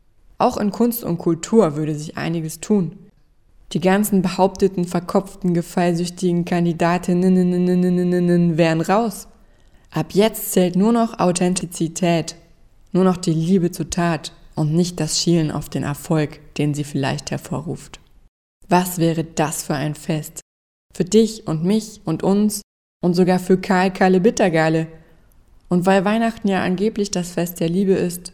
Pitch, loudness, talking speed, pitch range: 180 Hz, -19 LUFS, 140 wpm, 160-195 Hz